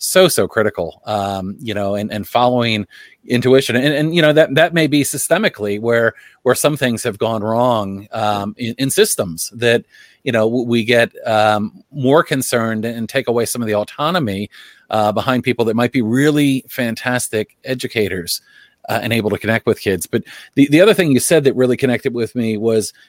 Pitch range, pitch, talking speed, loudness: 110-130 Hz, 120 Hz, 190 wpm, -16 LUFS